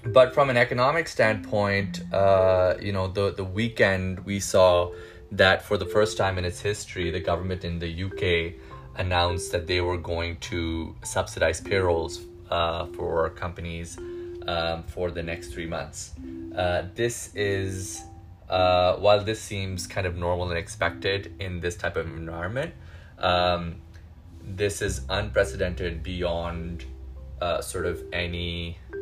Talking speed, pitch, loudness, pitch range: 145 wpm, 90 Hz, -26 LUFS, 85-95 Hz